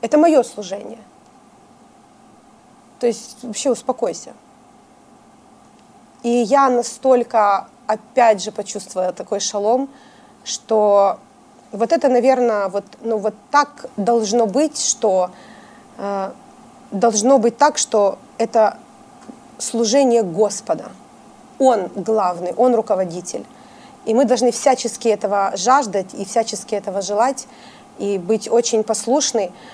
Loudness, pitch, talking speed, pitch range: -18 LUFS, 235 Hz, 105 wpm, 210-255 Hz